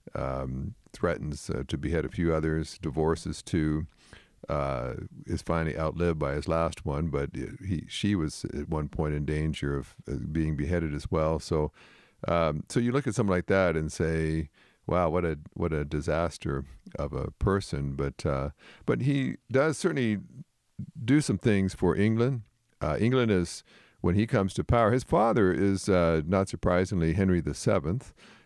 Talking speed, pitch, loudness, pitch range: 170 wpm, 85 Hz, -29 LUFS, 75-100 Hz